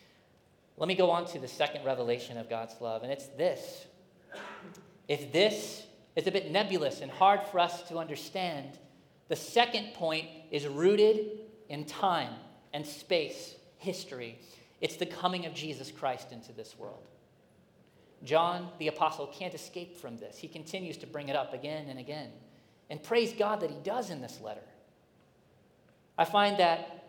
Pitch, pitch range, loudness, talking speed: 165 Hz, 145-185 Hz, -32 LUFS, 160 wpm